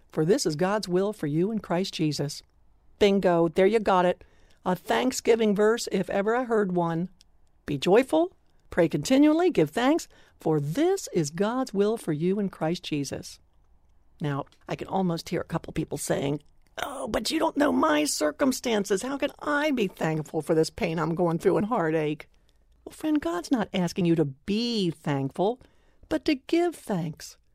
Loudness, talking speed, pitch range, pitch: -26 LUFS, 175 wpm, 160-245 Hz, 185 Hz